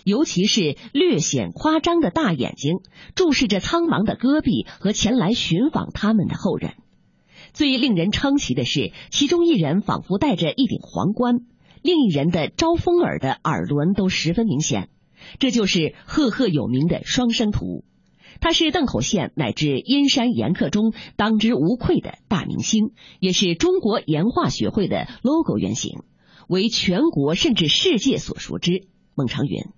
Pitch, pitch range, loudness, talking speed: 220 Hz, 185-280 Hz, -20 LUFS, 245 characters per minute